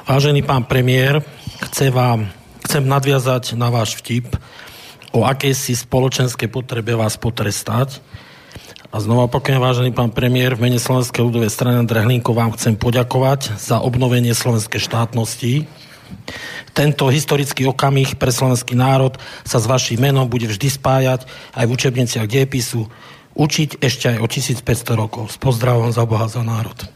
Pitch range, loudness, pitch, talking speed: 115-135 Hz, -17 LUFS, 125 Hz, 145 wpm